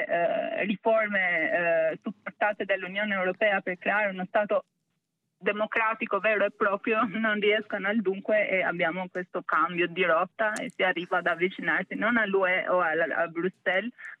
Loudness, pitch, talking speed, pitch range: -27 LUFS, 200 Hz, 150 wpm, 180-215 Hz